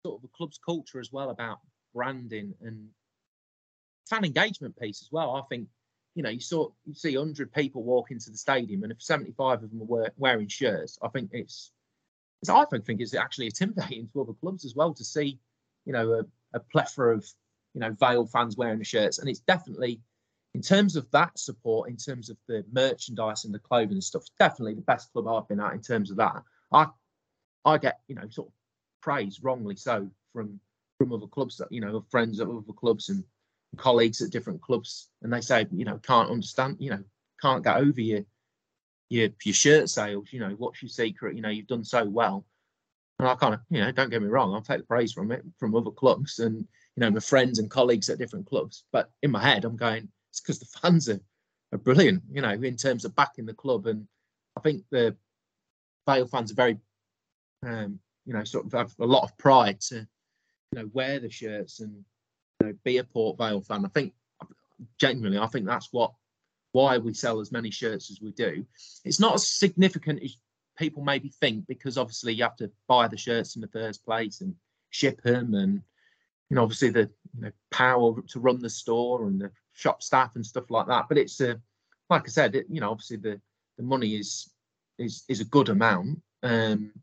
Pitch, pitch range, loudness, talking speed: 120 Hz, 110-135 Hz, -27 LUFS, 215 wpm